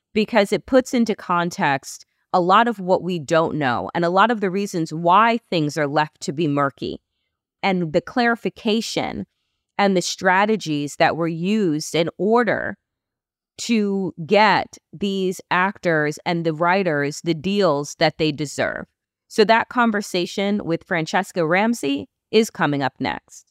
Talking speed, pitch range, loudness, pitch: 150 wpm, 160-205 Hz, -20 LUFS, 180 Hz